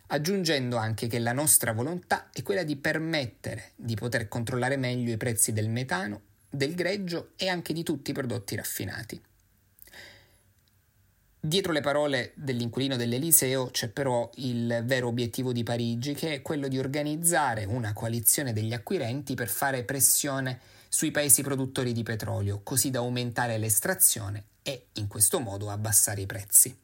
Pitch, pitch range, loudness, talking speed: 125 Hz, 110-140 Hz, -27 LUFS, 150 wpm